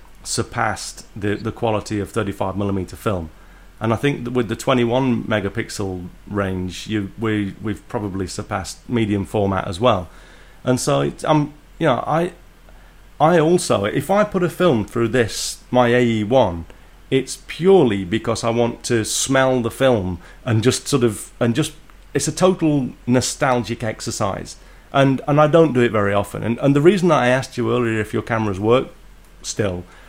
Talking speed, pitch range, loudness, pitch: 170 wpm, 100-130 Hz, -19 LUFS, 115 Hz